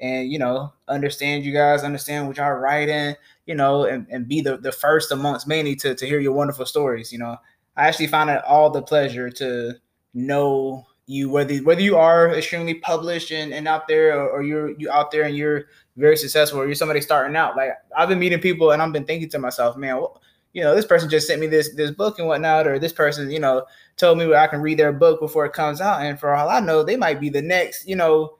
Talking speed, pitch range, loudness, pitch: 245 wpm, 140-155 Hz, -20 LUFS, 150 Hz